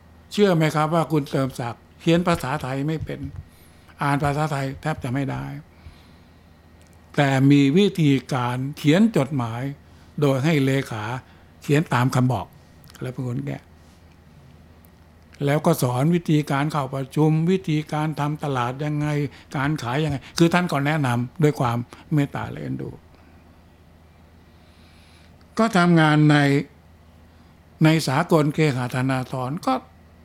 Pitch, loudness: 135 Hz, -22 LUFS